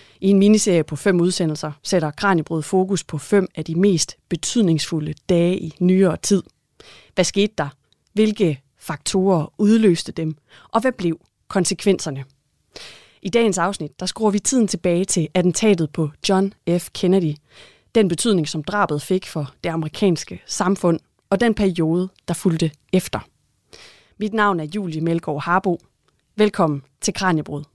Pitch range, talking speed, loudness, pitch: 155-195 Hz, 145 wpm, -20 LUFS, 180 Hz